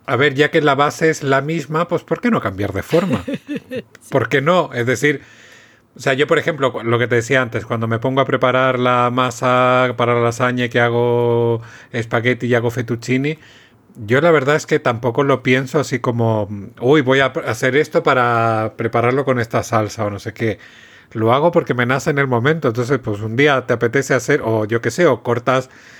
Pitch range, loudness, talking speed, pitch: 120-145 Hz, -17 LUFS, 210 wpm, 125 Hz